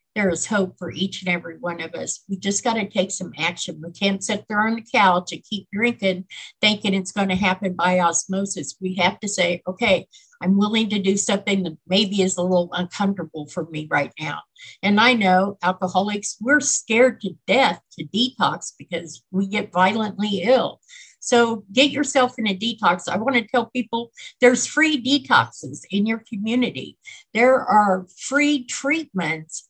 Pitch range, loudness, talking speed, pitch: 180-230 Hz, -21 LUFS, 180 wpm, 200 Hz